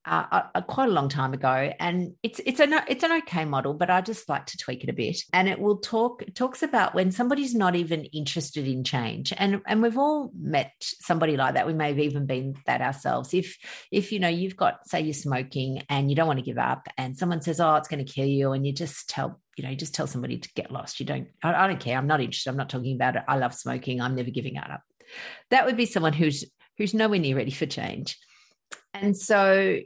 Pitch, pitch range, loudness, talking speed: 165 Hz, 135-205 Hz, -26 LUFS, 250 wpm